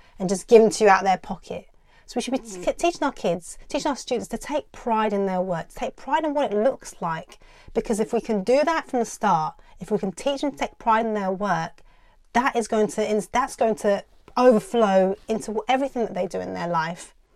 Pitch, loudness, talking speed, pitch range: 220 Hz, -23 LUFS, 250 wpm, 195-260 Hz